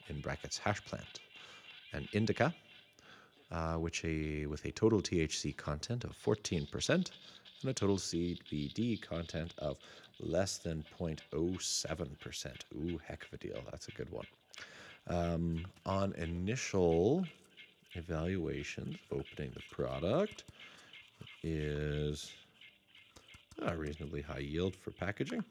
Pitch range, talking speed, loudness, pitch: 80-105 Hz, 115 wpm, -38 LUFS, 85 Hz